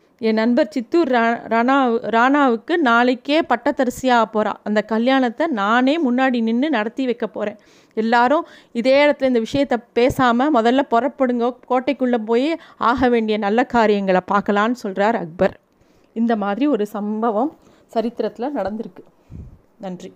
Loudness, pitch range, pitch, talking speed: -18 LUFS, 220-265 Hz, 235 Hz, 120 wpm